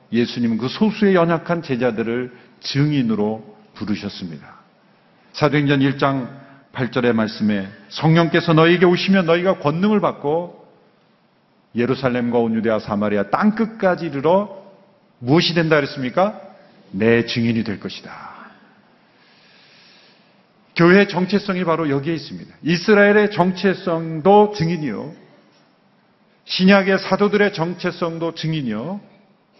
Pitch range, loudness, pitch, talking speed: 125-195 Hz, -18 LUFS, 165 Hz, 275 characters per minute